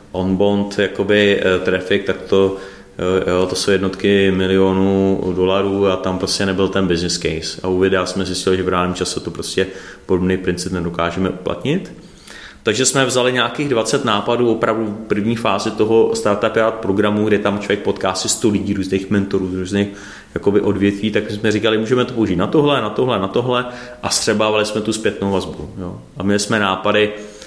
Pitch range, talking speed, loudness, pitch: 95-110 Hz, 180 wpm, -17 LUFS, 100 Hz